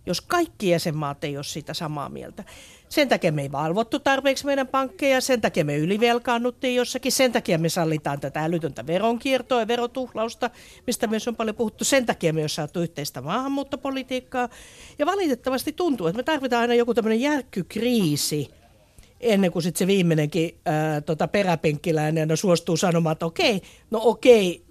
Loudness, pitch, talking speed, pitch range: -23 LUFS, 220 Hz, 160 wpm, 165-255 Hz